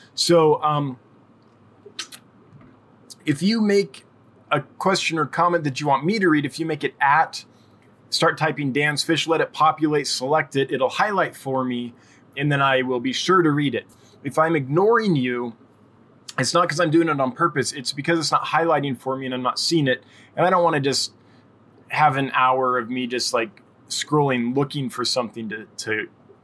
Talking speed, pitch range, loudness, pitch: 195 wpm, 125-160 Hz, -21 LUFS, 140 Hz